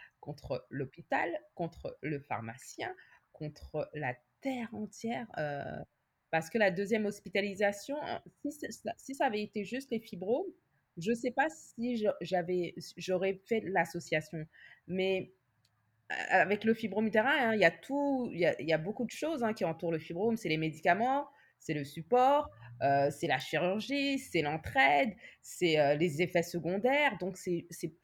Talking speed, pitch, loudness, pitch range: 155 wpm, 190 Hz, -33 LUFS, 165-240 Hz